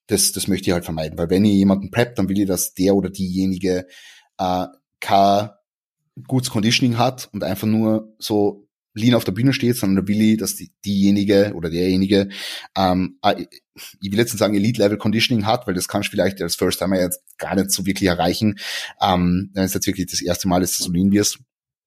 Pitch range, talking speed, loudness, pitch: 90-110 Hz, 210 wpm, -19 LUFS, 100 Hz